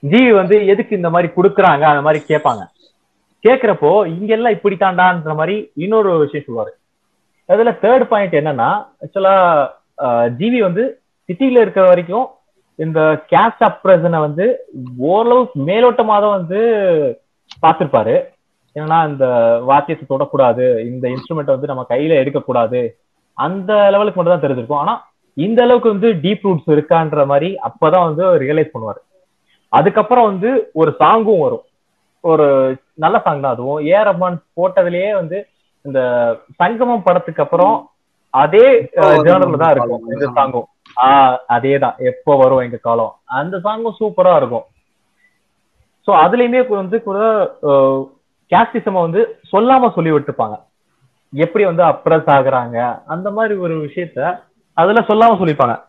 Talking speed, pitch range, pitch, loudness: 125 wpm, 150-220 Hz, 180 Hz, -13 LUFS